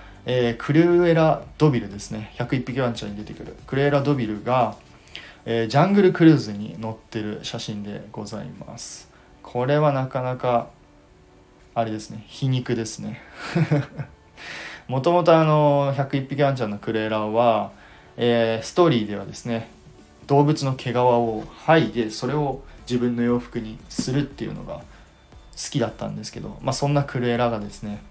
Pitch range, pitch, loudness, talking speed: 110-140 Hz, 120 Hz, -22 LUFS, 320 characters per minute